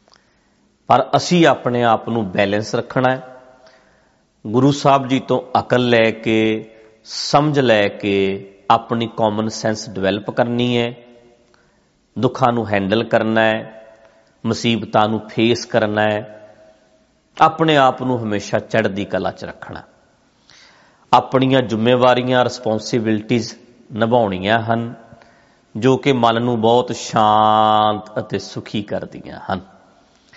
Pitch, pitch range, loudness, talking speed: 115 Hz, 110-125 Hz, -17 LUFS, 115 wpm